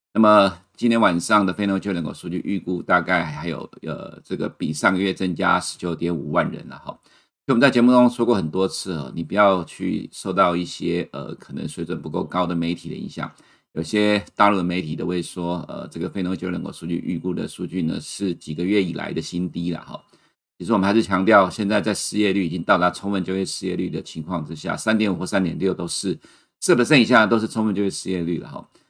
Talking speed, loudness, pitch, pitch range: 345 characters per minute, -21 LUFS, 95 Hz, 85-105 Hz